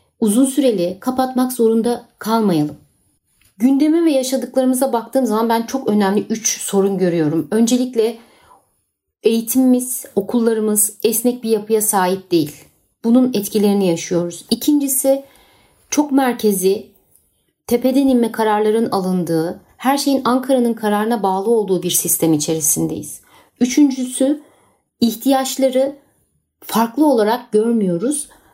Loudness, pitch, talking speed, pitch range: -17 LUFS, 230 Hz, 100 wpm, 200-260 Hz